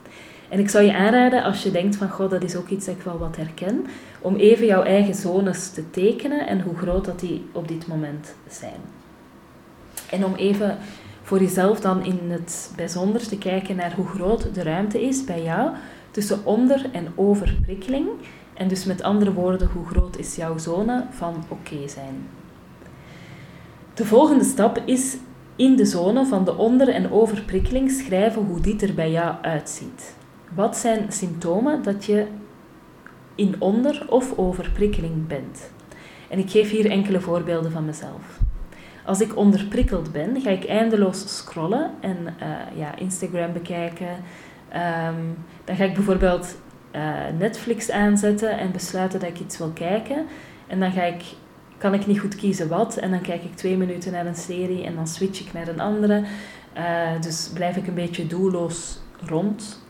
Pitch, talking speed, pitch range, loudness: 190 Hz, 170 wpm, 170-210 Hz, -22 LUFS